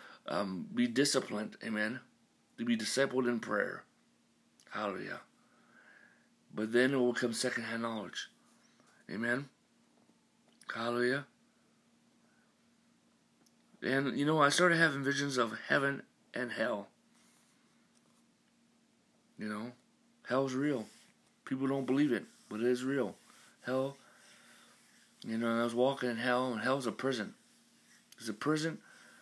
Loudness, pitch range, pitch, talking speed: -34 LUFS, 120-170 Hz, 135 Hz, 120 wpm